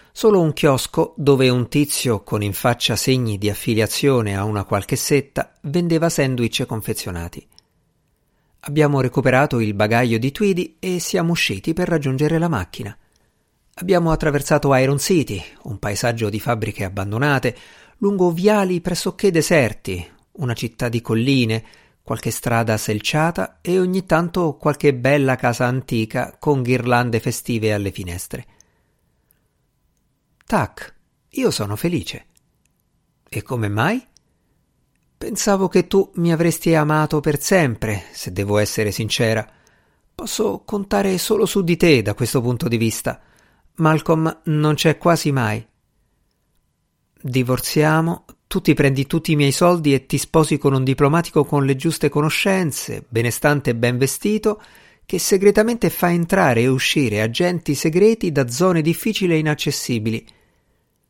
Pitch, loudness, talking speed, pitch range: 145 Hz, -19 LUFS, 130 wpm, 115-170 Hz